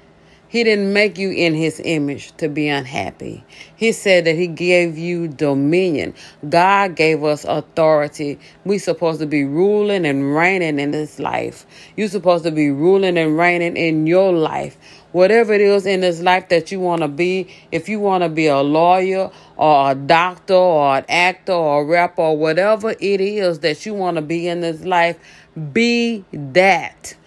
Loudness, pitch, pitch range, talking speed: -16 LUFS, 170 Hz, 155-190 Hz, 185 wpm